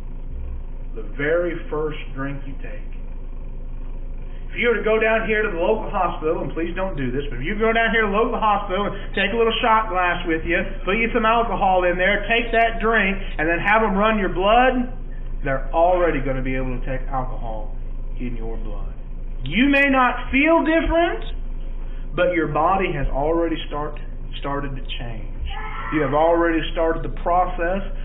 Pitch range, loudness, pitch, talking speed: 135-220 Hz, -20 LUFS, 170 Hz, 190 wpm